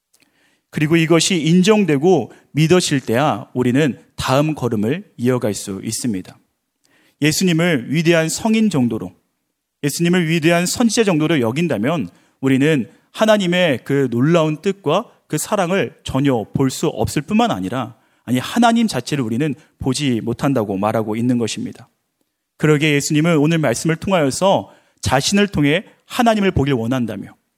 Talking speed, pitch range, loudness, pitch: 320 characters per minute, 130-175 Hz, -17 LUFS, 150 Hz